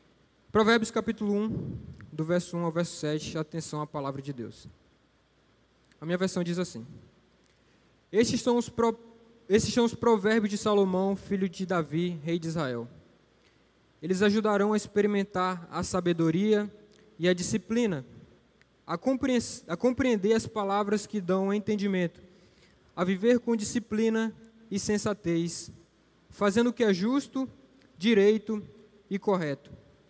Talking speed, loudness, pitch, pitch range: 135 wpm, -28 LUFS, 200 Hz, 170-220 Hz